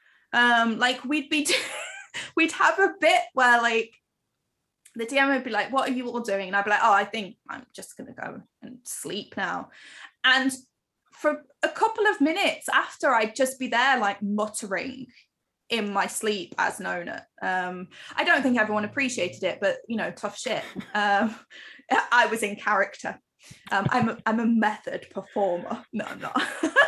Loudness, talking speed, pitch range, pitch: -25 LUFS, 180 wpm, 210-275 Hz, 235 Hz